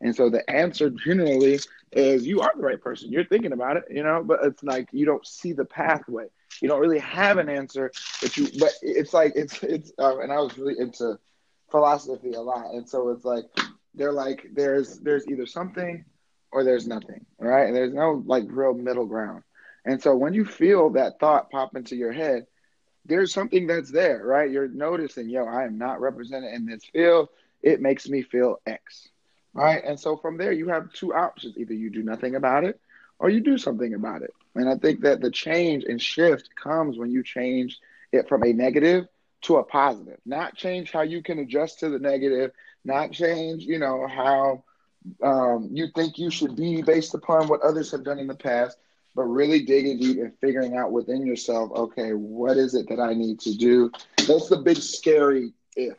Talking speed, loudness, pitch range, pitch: 205 wpm, -24 LUFS, 125-160 Hz, 135 Hz